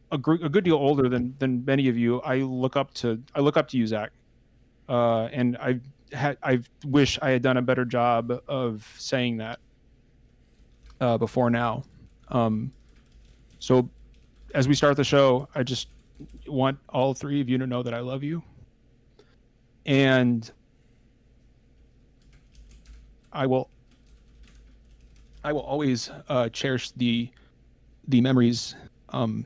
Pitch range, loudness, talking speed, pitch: 120-135 Hz, -25 LUFS, 140 wpm, 125 Hz